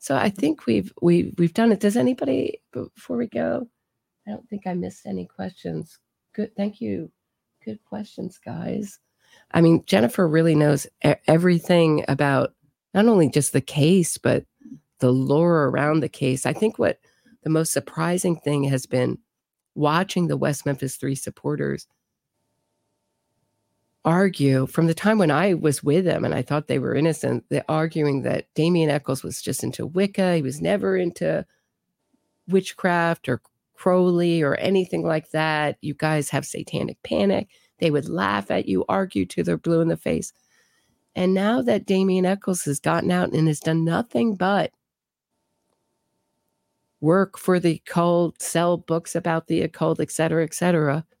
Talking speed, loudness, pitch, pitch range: 160 wpm, -22 LUFS, 165 Hz, 150-185 Hz